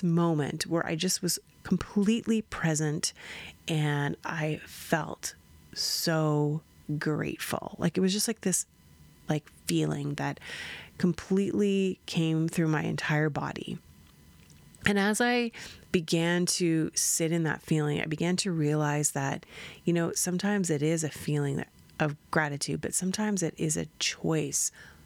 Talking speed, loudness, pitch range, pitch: 135 wpm, -29 LUFS, 150-180 Hz, 160 Hz